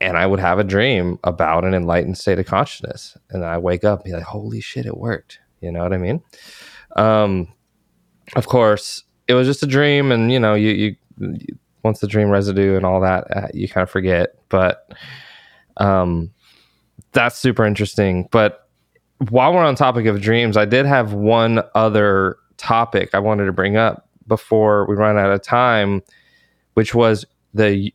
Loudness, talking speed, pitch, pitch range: -17 LUFS, 185 wpm, 105 Hz, 95-115 Hz